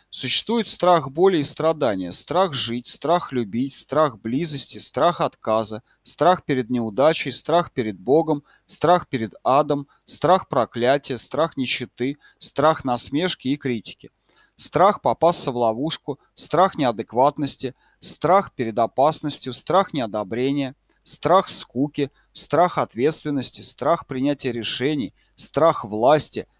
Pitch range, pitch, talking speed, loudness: 120-160 Hz, 140 Hz, 115 wpm, -22 LUFS